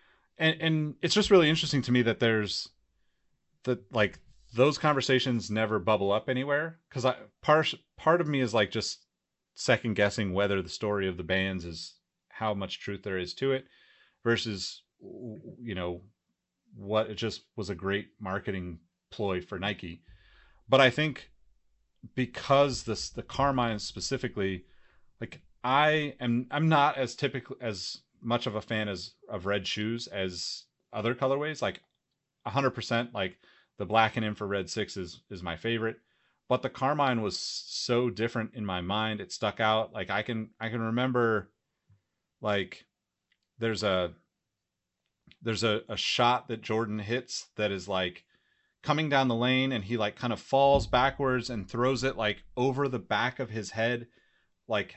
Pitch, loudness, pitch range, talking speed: 115 Hz, -29 LUFS, 100-130 Hz, 165 wpm